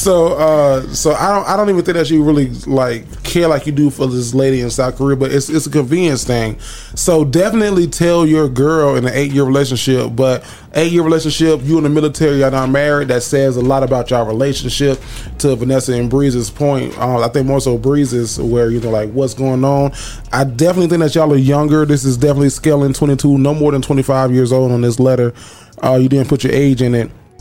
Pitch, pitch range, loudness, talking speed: 140 Hz, 130-150 Hz, -13 LUFS, 225 wpm